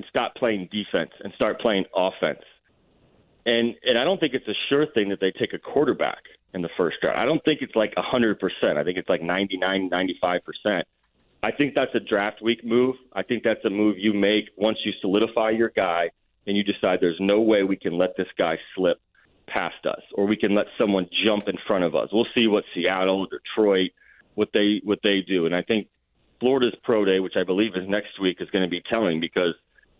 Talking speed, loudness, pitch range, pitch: 220 wpm, -24 LUFS, 95-110 Hz, 105 Hz